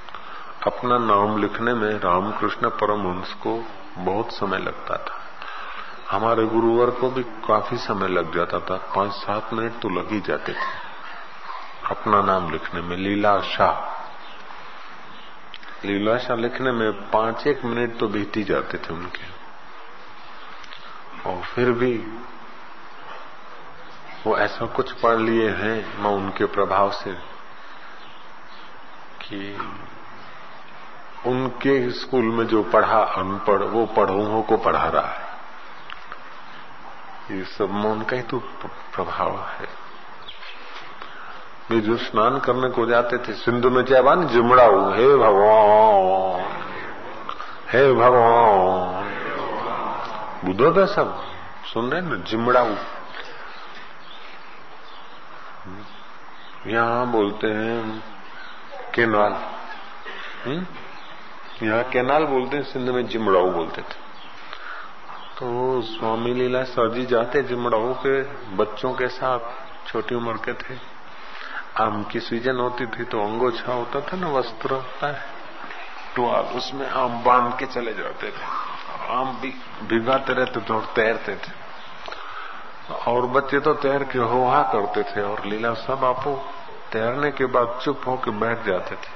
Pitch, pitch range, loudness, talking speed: 120 Hz, 110-125 Hz, -22 LUFS, 125 wpm